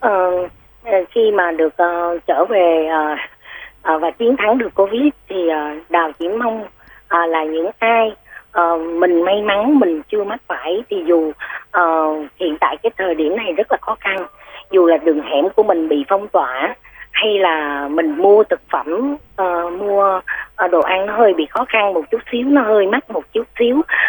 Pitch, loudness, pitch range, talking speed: 190 Hz, -16 LUFS, 170-225 Hz, 195 wpm